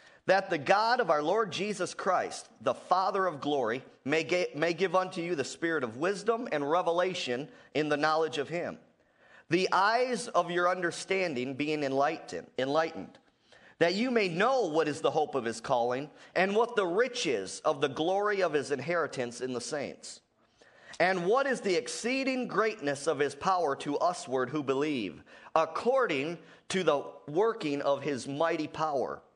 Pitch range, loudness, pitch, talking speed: 145-190 Hz, -30 LUFS, 165 Hz, 165 wpm